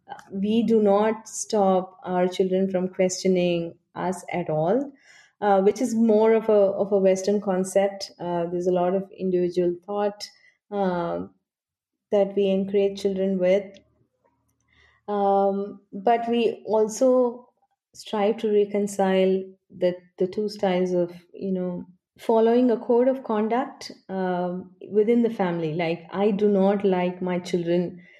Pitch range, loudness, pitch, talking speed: 180-215 Hz, -24 LUFS, 195 Hz, 135 wpm